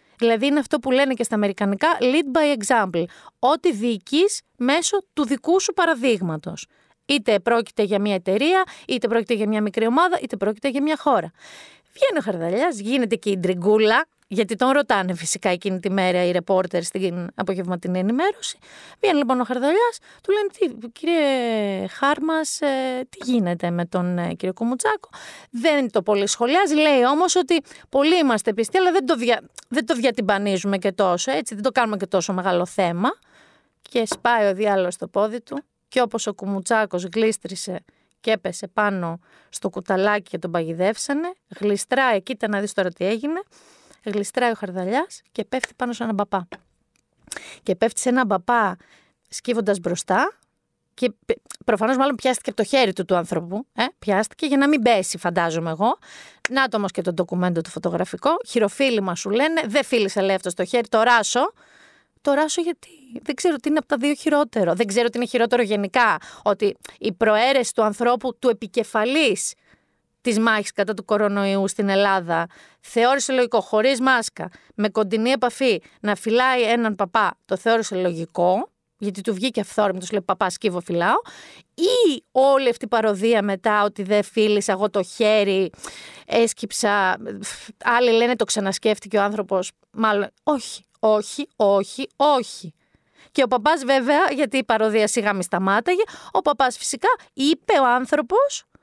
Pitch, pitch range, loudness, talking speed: 225 Hz, 200-270 Hz, -21 LUFS, 160 wpm